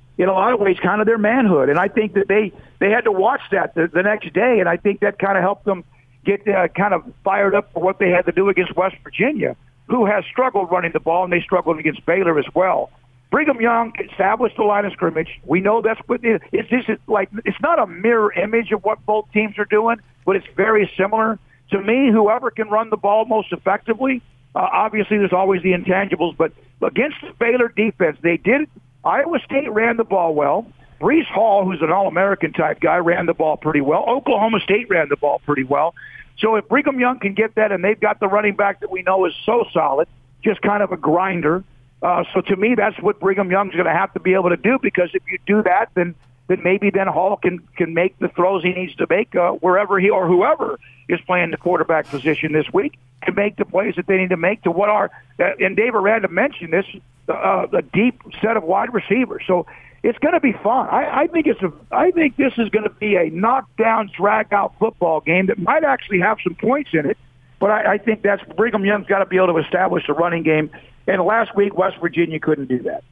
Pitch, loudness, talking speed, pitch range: 195 Hz, -18 LUFS, 235 wpm, 175-215 Hz